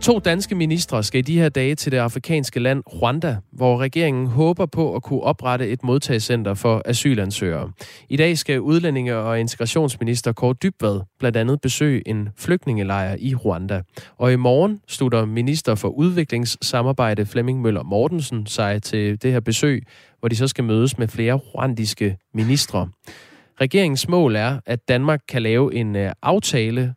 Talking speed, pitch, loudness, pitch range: 160 wpm, 125 Hz, -20 LUFS, 115-145 Hz